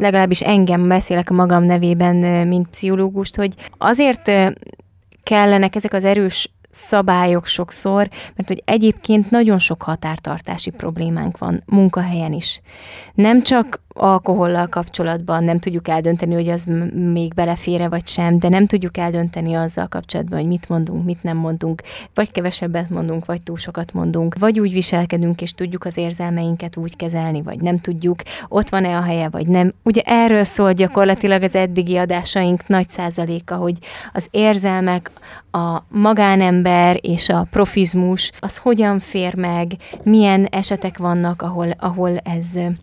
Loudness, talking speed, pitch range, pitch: -17 LUFS, 145 wpm, 170-195 Hz, 180 Hz